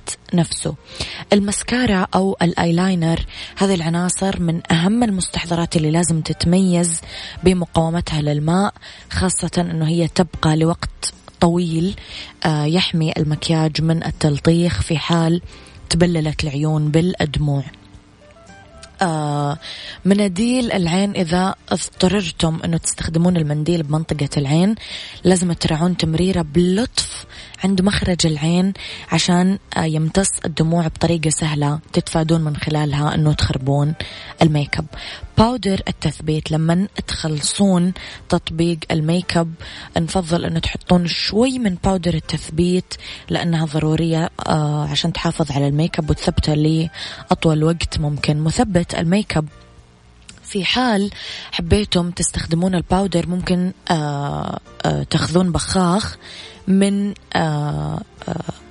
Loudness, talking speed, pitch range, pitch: -19 LUFS, 95 wpm, 155-180 Hz, 170 Hz